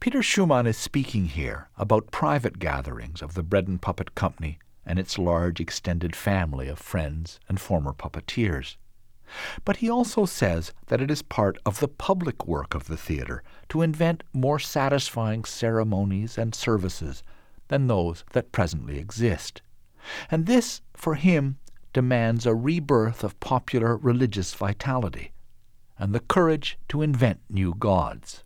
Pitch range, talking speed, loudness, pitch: 85-135 Hz, 145 wpm, -26 LUFS, 110 Hz